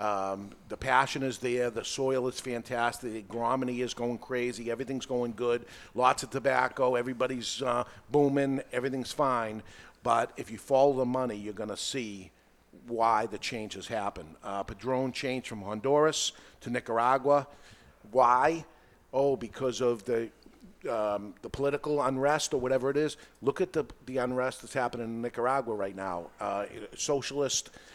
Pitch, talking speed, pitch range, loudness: 125 Hz, 150 wpm, 115-135 Hz, -30 LUFS